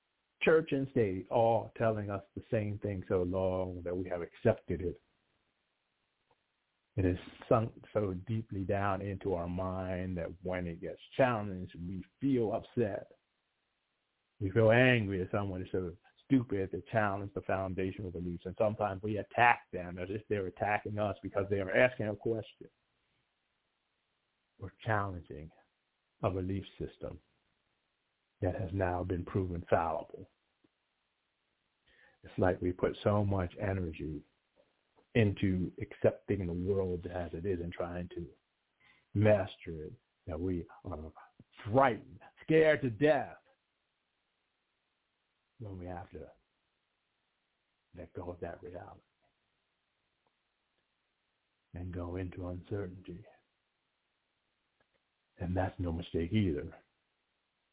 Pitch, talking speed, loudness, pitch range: 95 Hz, 125 wpm, -34 LUFS, 90-105 Hz